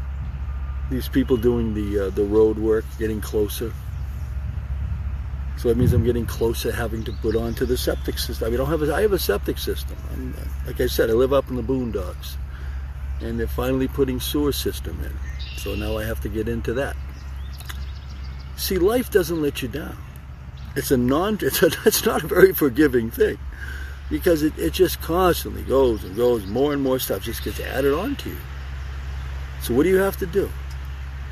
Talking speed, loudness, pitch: 200 wpm, -23 LUFS, 70 Hz